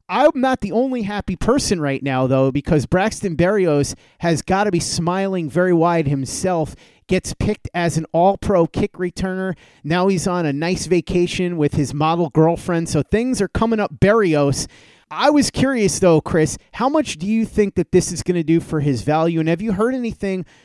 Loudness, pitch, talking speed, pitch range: -19 LUFS, 180 Hz, 200 wpm, 160-200 Hz